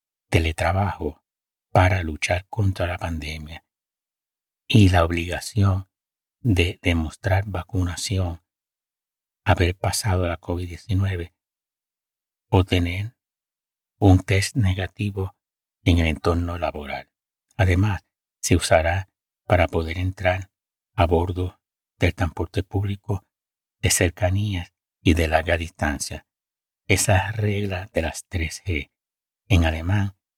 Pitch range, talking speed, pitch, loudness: 85-100 Hz, 95 wpm, 90 Hz, -23 LUFS